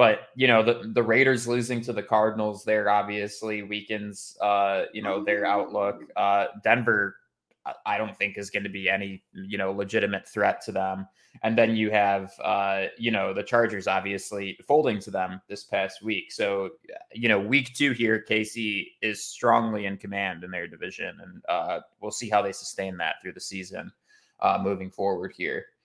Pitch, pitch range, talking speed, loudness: 105 Hz, 100-110 Hz, 185 wpm, -26 LUFS